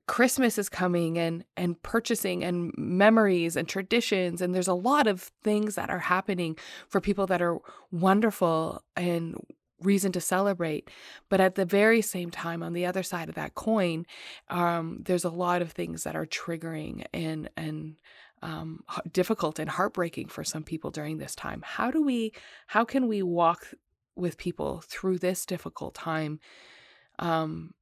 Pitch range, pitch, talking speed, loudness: 165-195 Hz, 180 Hz, 165 wpm, -28 LUFS